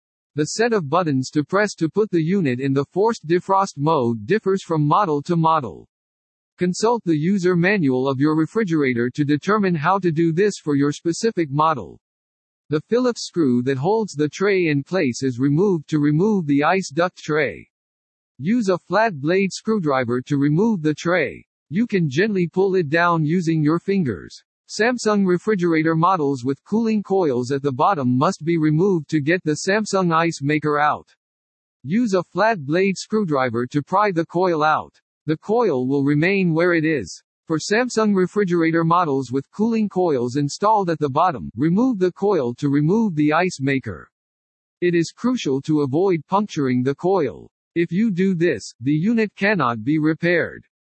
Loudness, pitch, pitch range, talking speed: -20 LUFS, 165 Hz, 145-195 Hz, 170 wpm